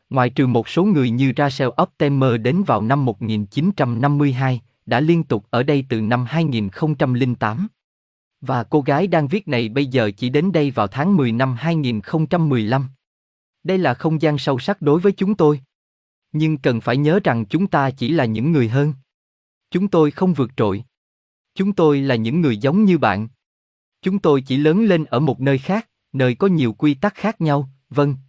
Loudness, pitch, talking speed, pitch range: -19 LUFS, 140 Hz, 185 wpm, 120-160 Hz